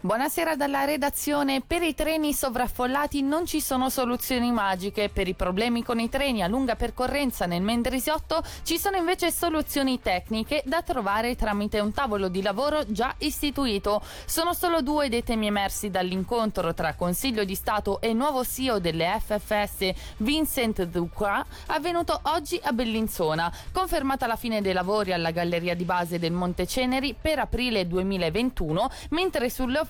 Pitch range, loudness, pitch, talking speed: 200-290 Hz, -26 LUFS, 240 Hz, 155 wpm